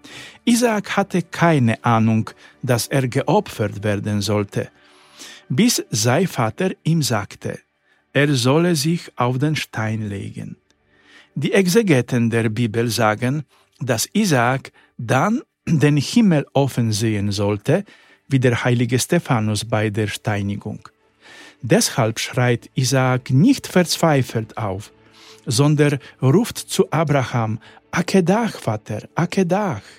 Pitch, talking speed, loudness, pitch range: 130 Hz, 110 wpm, -19 LUFS, 110-165 Hz